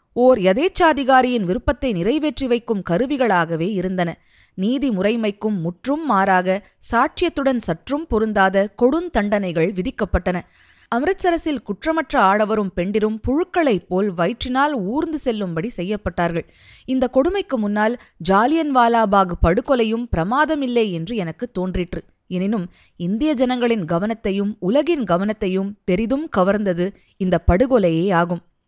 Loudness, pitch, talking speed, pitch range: -19 LUFS, 215 Hz, 95 wpm, 185-260 Hz